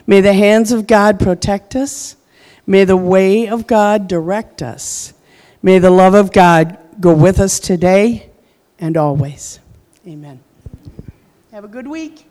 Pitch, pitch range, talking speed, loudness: 195 Hz, 175-215 Hz, 145 wpm, -12 LUFS